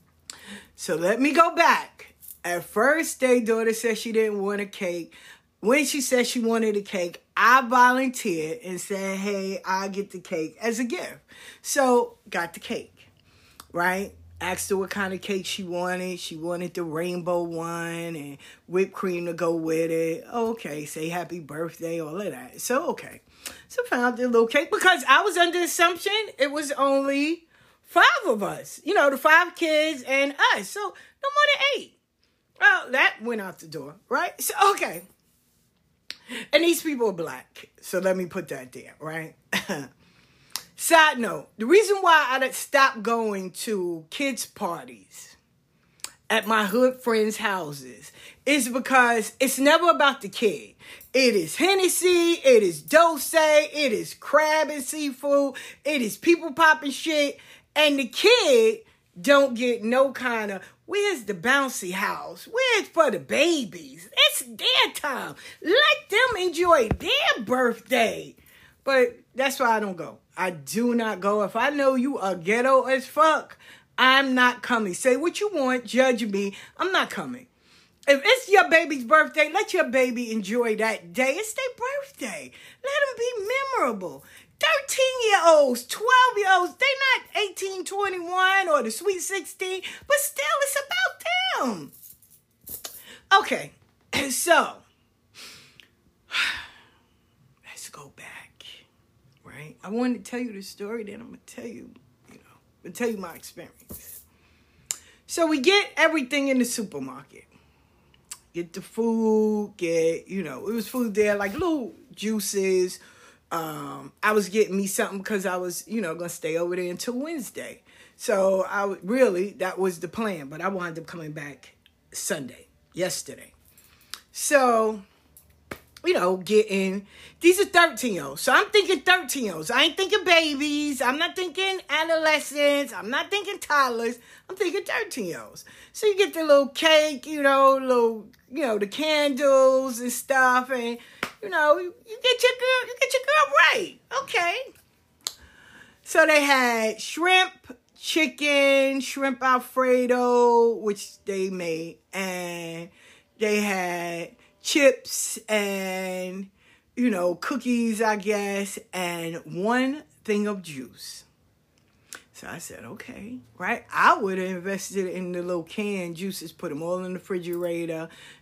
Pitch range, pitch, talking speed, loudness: 195-310 Hz, 245 Hz, 150 wpm, -23 LUFS